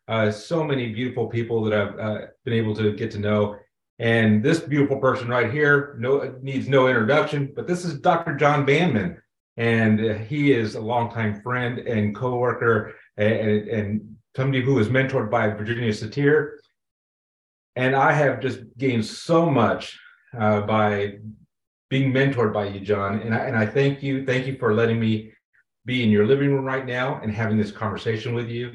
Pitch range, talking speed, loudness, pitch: 110-135 Hz, 185 wpm, -22 LUFS, 120 Hz